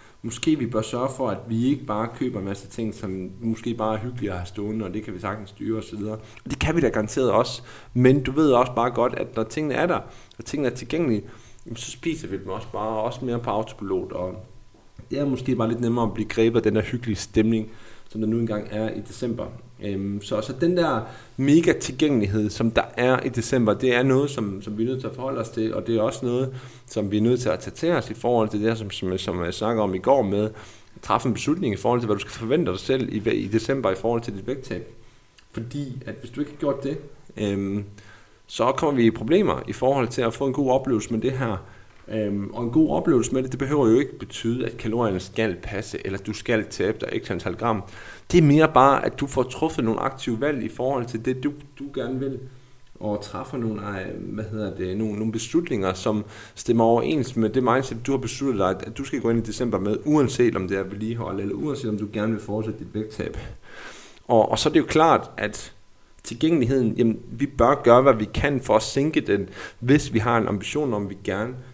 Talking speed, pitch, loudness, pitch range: 245 wpm, 115 Hz, -24 LUFS, 105-130 Hz